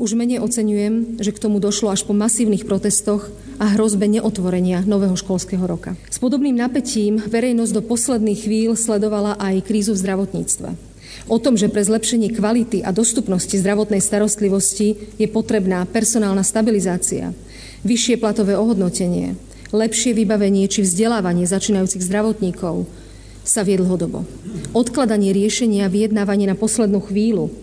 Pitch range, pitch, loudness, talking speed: 195-220 Hz, 210 Hz, -18 LUFS, 130 wpm